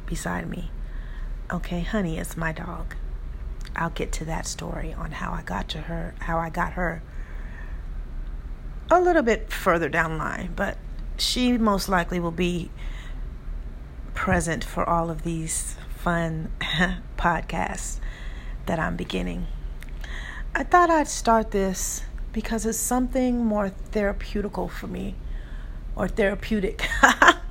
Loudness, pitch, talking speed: -25 LUFS, 170 Hz, 125 wpm